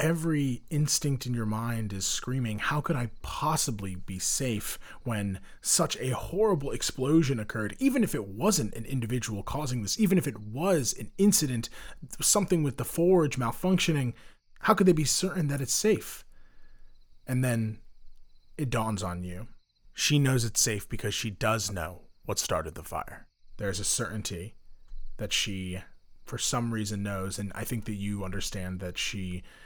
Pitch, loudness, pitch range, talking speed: 115 Hz, -29 LUFS, 100-150 Hz, 165 wpm